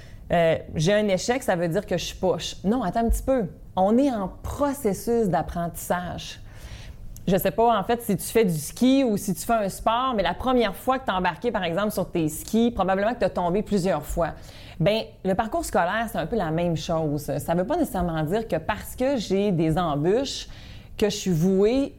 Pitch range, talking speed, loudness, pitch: 175-230 Hz, 225 wpm, -24 LUFS, 200 Hz